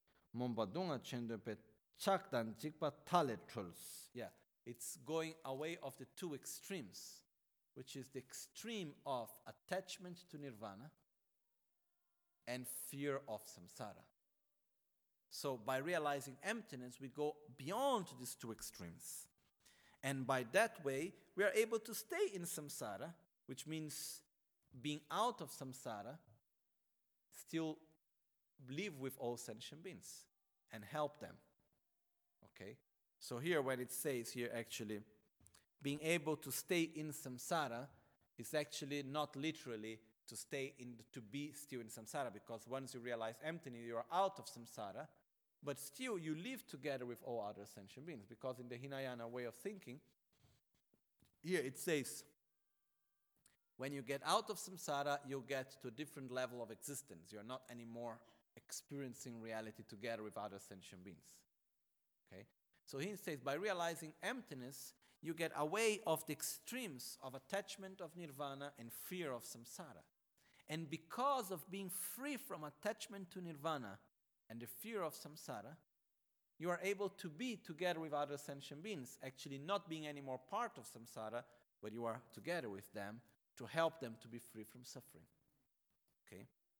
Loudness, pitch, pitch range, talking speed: -46 LUFS, 140 Hz, 120-165 Hz, 140 wpm